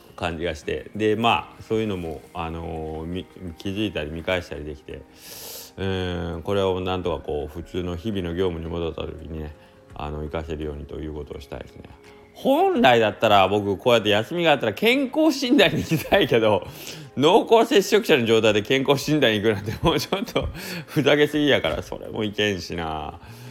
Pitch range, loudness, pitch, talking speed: 80-115 Hz, -22 LUFS, 100 Hz, 375 characters per minute